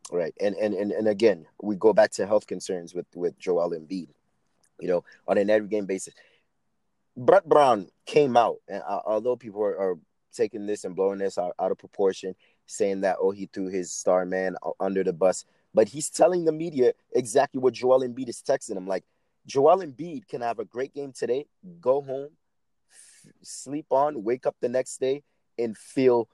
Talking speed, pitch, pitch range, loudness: 195 wpm, 130 Hz, 100-165 Hz, -26 LUFS